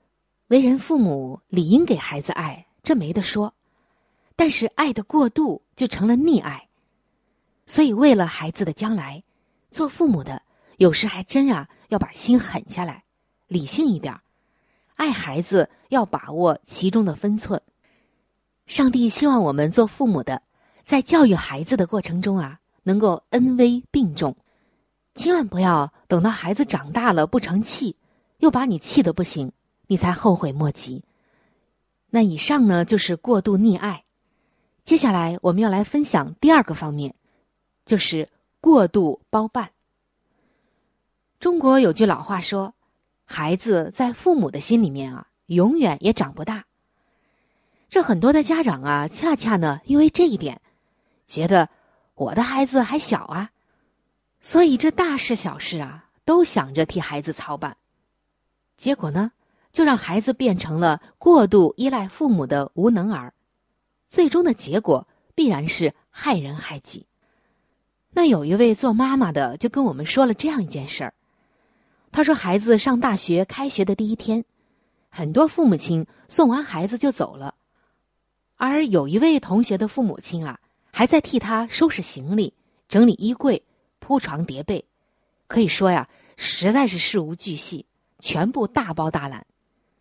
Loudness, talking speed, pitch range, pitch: -20 LUFS, 220 characters per minute, 175-265 Hz, 215 Hz